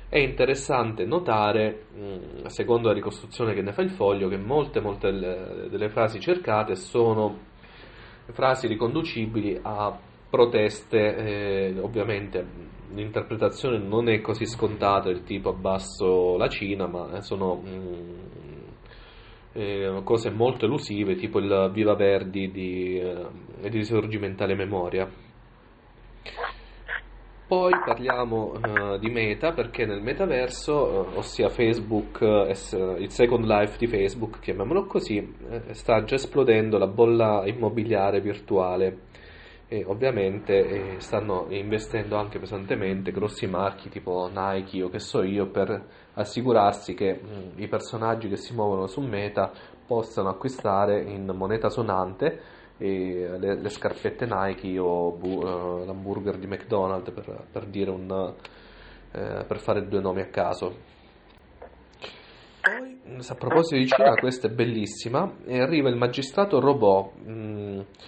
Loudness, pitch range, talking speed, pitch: -26 LUFS, 95-115 Hz, 125 wpm, 105 Hz